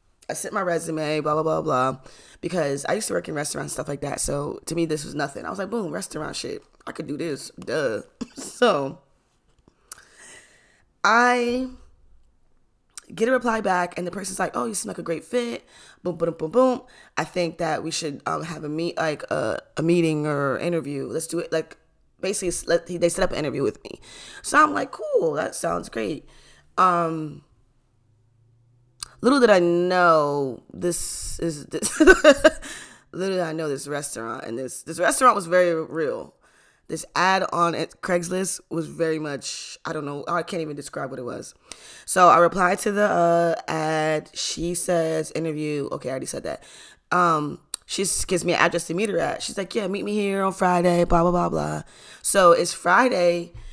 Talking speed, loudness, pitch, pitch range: 190 wpm, -23 LUFS, 170 Hz, 150-190 Hz